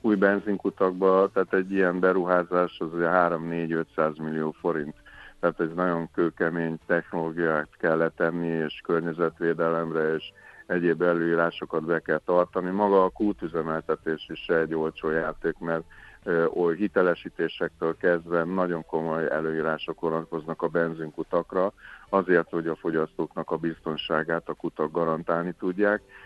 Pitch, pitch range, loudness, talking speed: 85 Hz, 80-90 Hz, -26 LUFS, 120 wpm